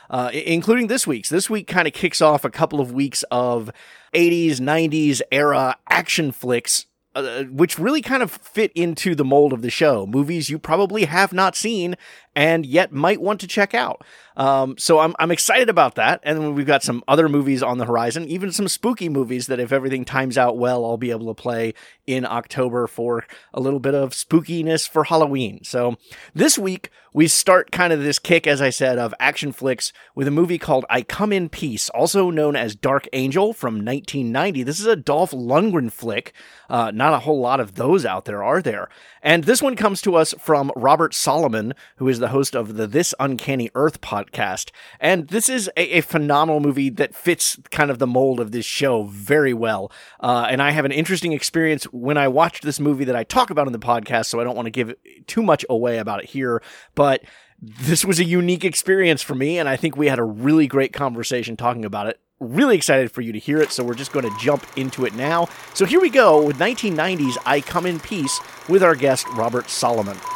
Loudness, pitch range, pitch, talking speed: -19 LUFS, 125-170 Hz, 145 Hz, 215 wpm